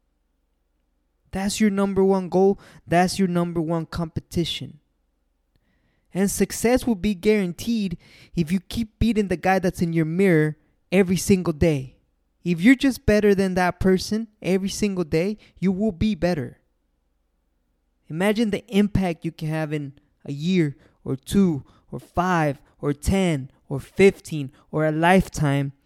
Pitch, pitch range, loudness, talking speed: 175 Hz, 140-195 Hz, -22 LUFS, 145 wpm